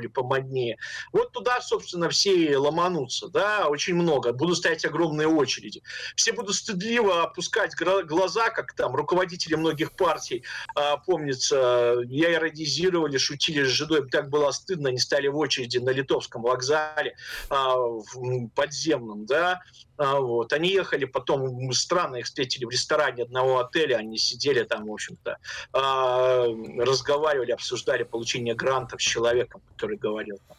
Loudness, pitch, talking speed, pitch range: -25 LUFS, 145 Hz, 140 wpm, 125-180 Hz